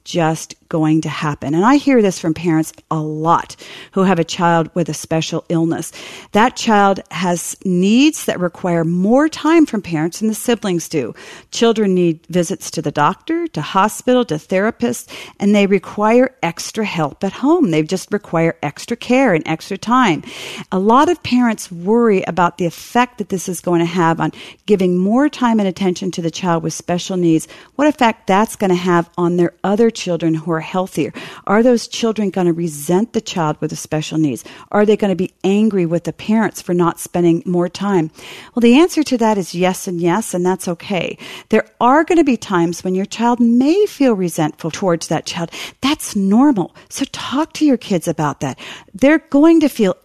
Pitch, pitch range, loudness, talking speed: 185 Hz, 170-225 Hz, -16 LUFS, 195 wpm